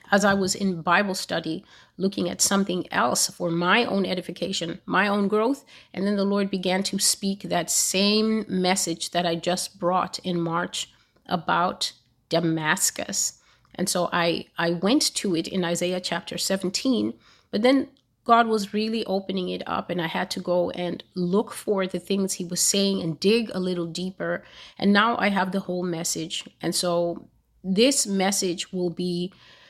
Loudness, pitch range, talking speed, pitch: -24 LUFS, 175-200 Hz, 170 wpm, 185 Hz